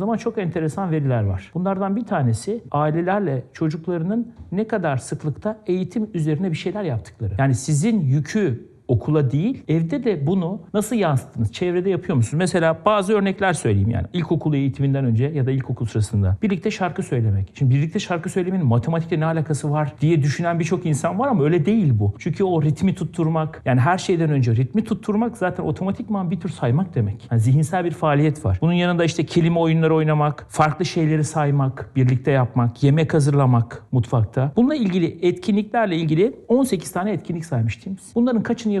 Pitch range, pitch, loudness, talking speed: 135-190 Hz, 160 Hz, -21 LUFS, 165 wpm